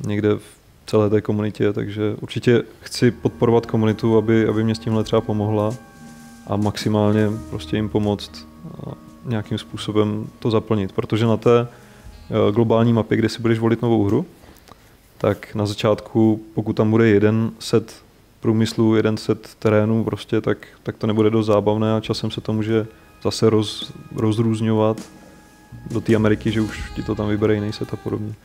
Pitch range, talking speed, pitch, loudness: 105-115 Hz, 160 wpm, 110 Hz, -20 LUFS